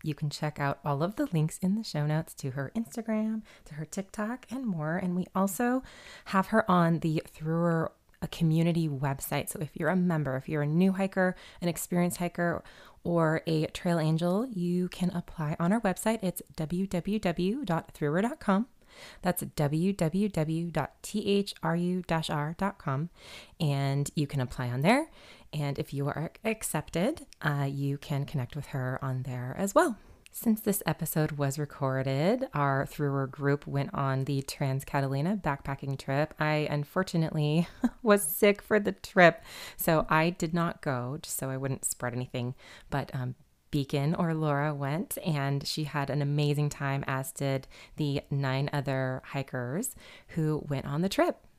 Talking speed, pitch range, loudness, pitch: 155 wpm, 140-185 Hz, -30 LUFS, 160 Hz